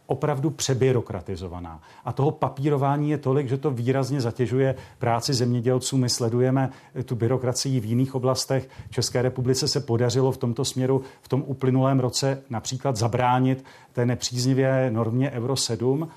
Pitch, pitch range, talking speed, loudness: 130 Hz, 125-135 Hz, 140 wpm, -24 LUFS